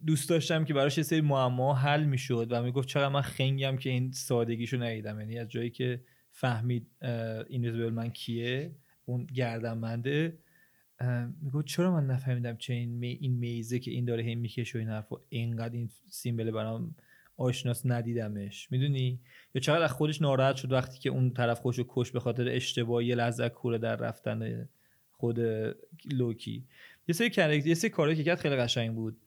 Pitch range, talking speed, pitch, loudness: 115-140 Hz, 170 wpm, 125 Hz, -31 LUFS